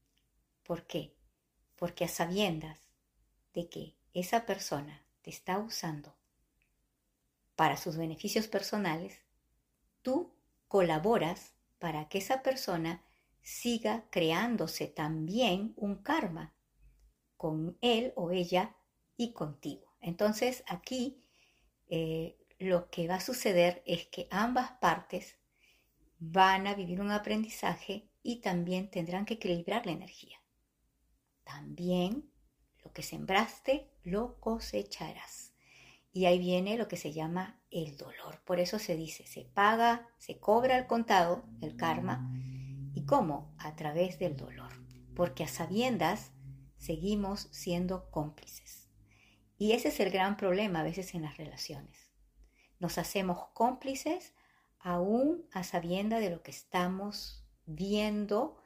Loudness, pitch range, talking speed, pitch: -34 LUFS, 165-215 Hz, 120 wpm, 180 Hz